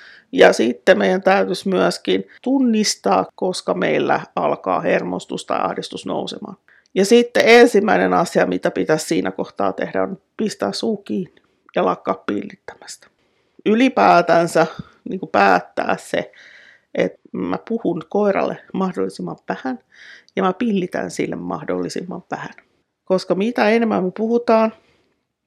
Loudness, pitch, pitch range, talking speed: -18 LUFS, 195 Hz, 180-225 Hz, 120 wpm